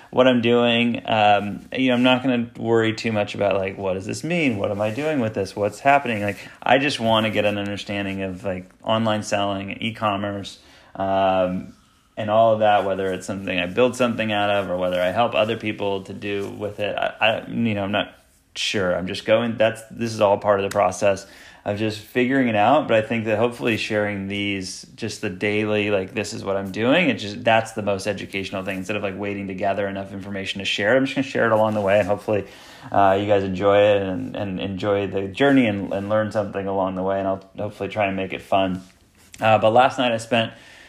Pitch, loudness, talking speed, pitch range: 105 Hz, -21 LUFS, 235 wpm, 100-110 Hz